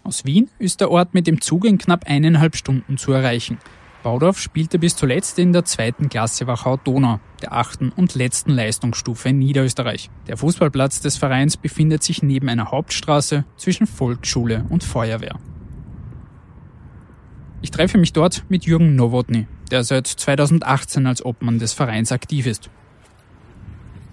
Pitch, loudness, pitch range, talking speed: 135 Hz, -18 LUFS, 120-160 Hz, 145 wpm